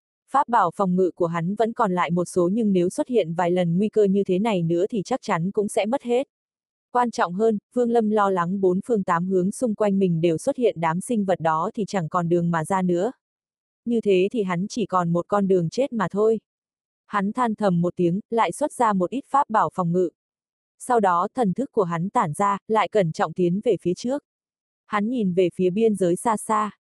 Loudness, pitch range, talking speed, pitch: -23 LUFS, 180-225 Hz, 240 wpm, 200 Hz